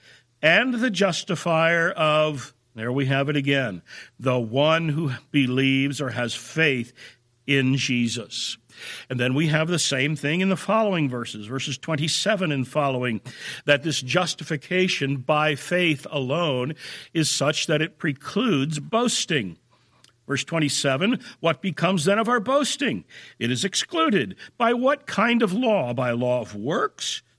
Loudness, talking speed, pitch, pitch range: -23 LUFS, 140 wpm, 150 Hz, 135-180 Hz